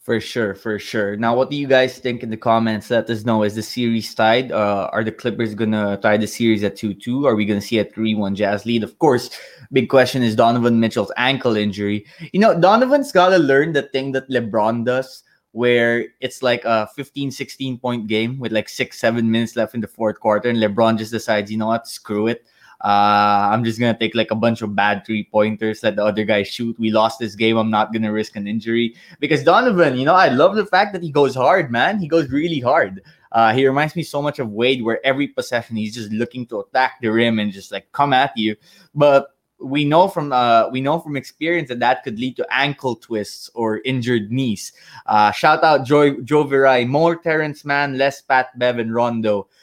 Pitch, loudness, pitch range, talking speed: 115 Hz, -18 LUFS, 110-135 Hz, 230 wpm